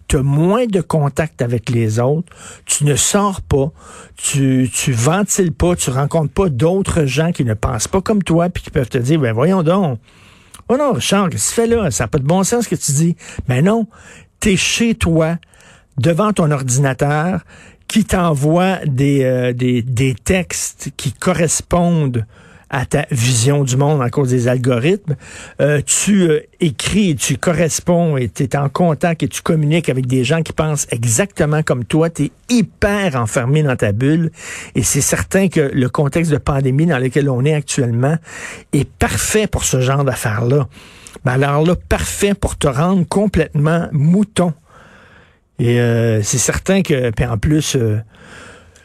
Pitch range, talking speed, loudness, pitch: 130-175 Hz, 180 wpm, -16 LUFS, 150 Hz